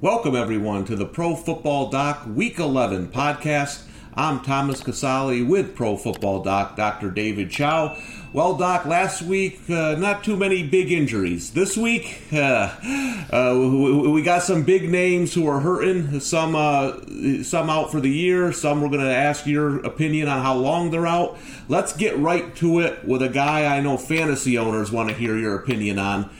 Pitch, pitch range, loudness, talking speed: 145 Hz, 125-170 Hz, -21 LUFS, 180 wpm